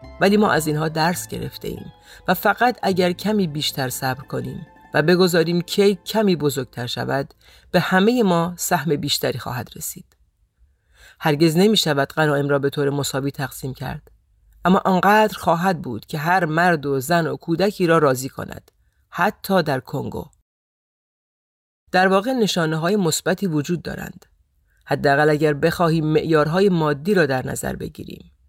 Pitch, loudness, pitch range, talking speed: 160 Hz, -20 LUFS, 140-185 Hz, 145 wpm